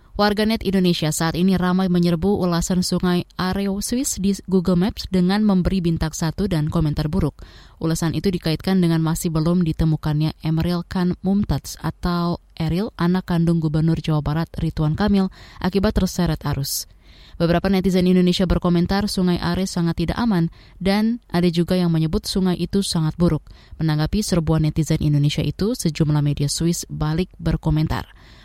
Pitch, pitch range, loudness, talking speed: 175 Hz, 160-190 Hz, -21 LUFS, 150 wpm